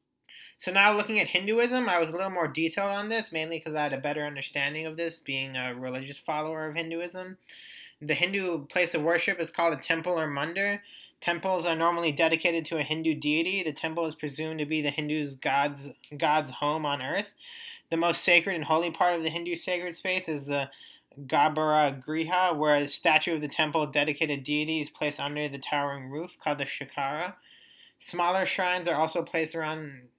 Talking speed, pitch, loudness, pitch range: 195 wpm, 160 Hz, -28 LUFS, 150-175 Hz